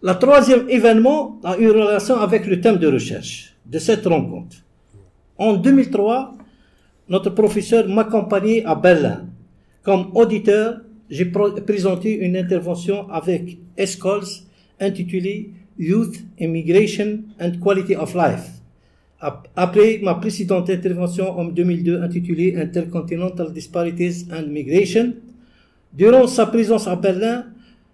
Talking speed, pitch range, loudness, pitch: 110 wpm, 175-220 Hz, -18 LUFS, 195 Hz